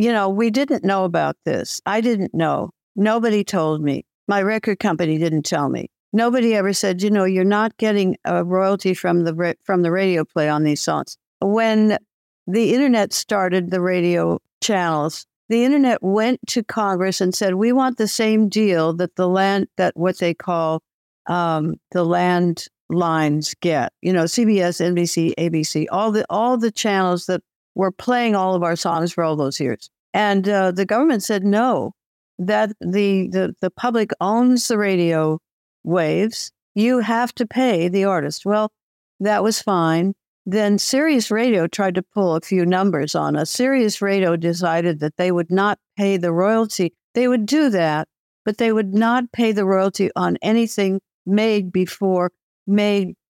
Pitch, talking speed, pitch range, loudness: 195 Hz, 170 wpm, 175-220 Hz, -19 LUFS